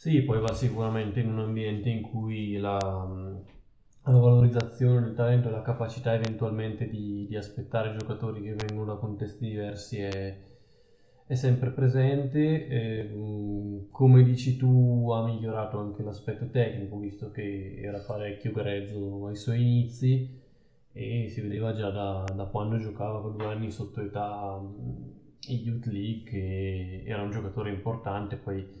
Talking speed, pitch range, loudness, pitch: 145 wpm, 100-120 Hz, -29 LUFS, 110 Hz